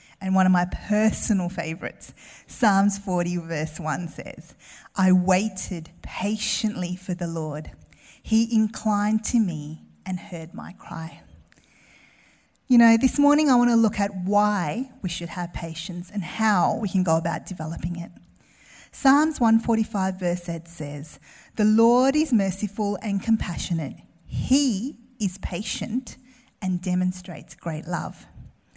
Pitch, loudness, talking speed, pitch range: 190 Hz, -24 LUFS, 135 wpm, 170-220 Hz